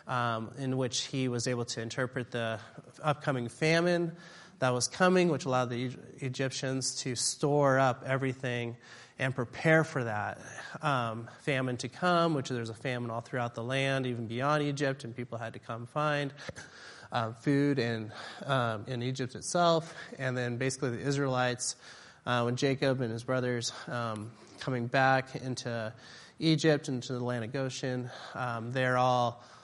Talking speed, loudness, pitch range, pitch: 160 wpm, -31 LUFS, 120-140 Hz, 130 Hz